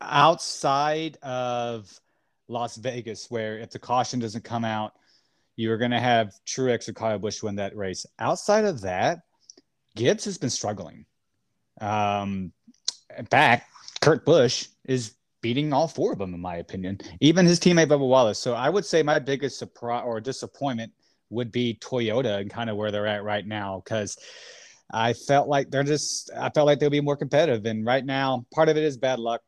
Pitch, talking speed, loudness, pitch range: 120 Hz, 185 wpm, -25 LUFS, 110-140 Hz